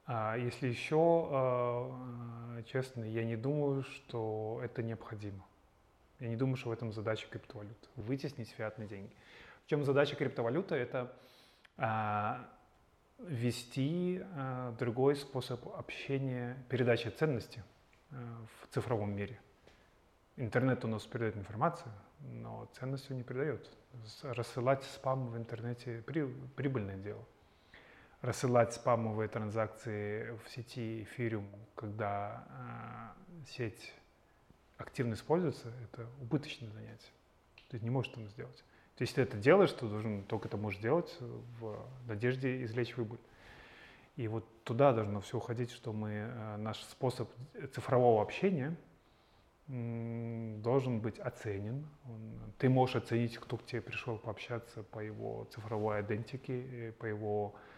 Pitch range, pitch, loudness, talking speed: 110-130 Hz, 120 Hz, -37 LUFS, 120 wpm